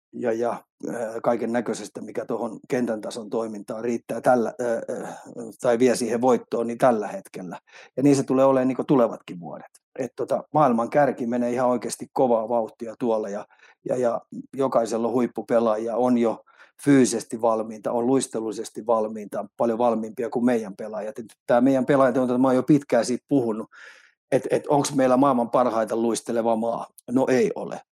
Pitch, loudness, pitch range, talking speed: 120 Hz, -23 LUFS, 115-130 Hz, 165 wpm